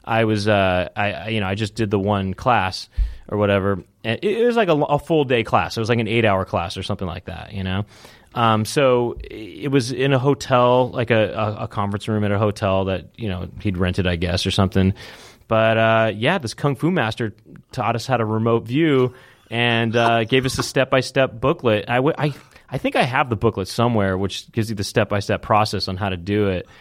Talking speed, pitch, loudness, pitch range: 235 wpm, 110 Hz, -20 LUFS, 100-125 Hz